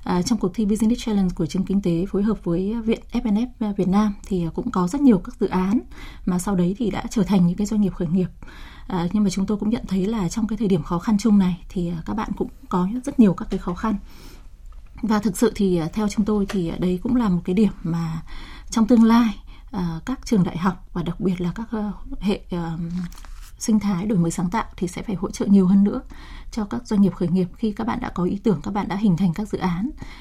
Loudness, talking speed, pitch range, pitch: -22 LUFS, 260 wpm, 180-220 Hz, 200 Hz